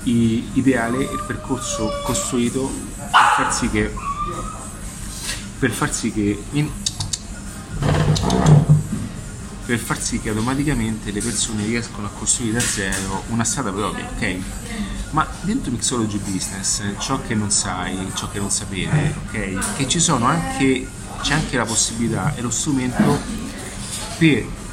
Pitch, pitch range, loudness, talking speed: 110 Hz, 100-125 Hz, -20 LUFS, 130 wpm